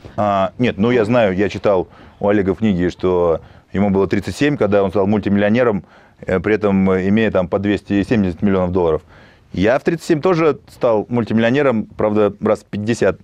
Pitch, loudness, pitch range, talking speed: 105 Hz, -17 LUFS, 95-110 Hz, 165 wpm